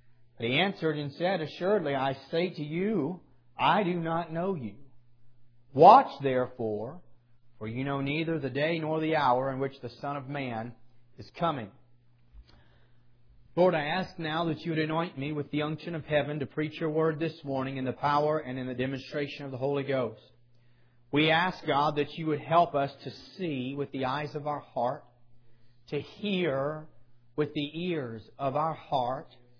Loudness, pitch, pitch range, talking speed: -29 LUFS, 140 Hz, 120-155 Hz, 180 wpm